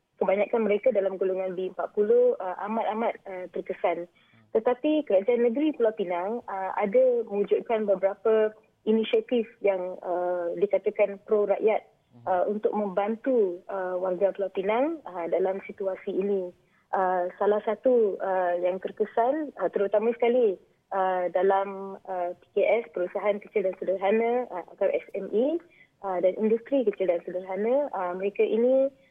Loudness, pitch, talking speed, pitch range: -27 LUFS, 200 Hz, 130 wpm, 185-230 Hz